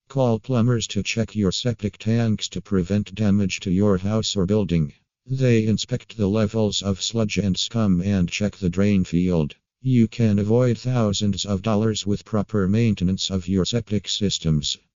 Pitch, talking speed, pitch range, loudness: 105 Hz, 165 wpm, 95-110 Hz, -22 LUFS